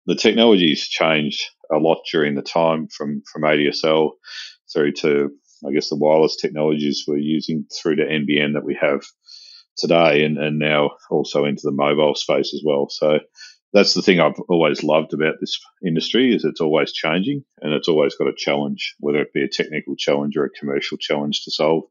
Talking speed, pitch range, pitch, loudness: 190 wpm, 75-80 Hz, 75 Hz, -19 LUFS